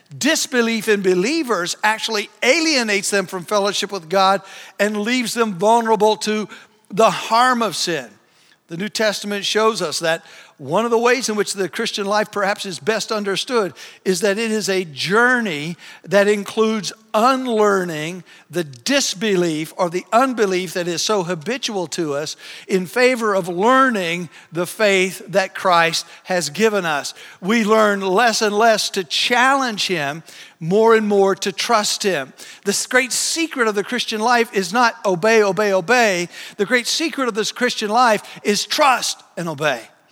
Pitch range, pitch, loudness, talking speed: 185-225 Hz, 210 Hz, -18 LUFS, 160 wpm